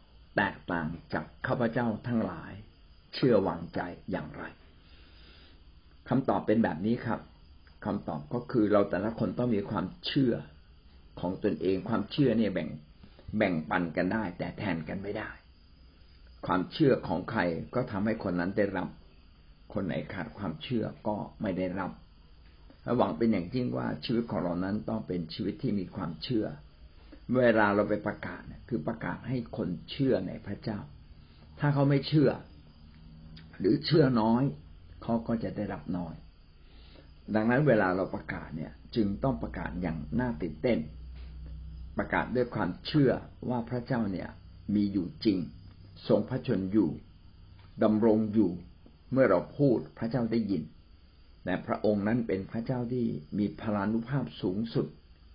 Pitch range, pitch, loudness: 75-110 Hz, 90 Hz, -31 LUFS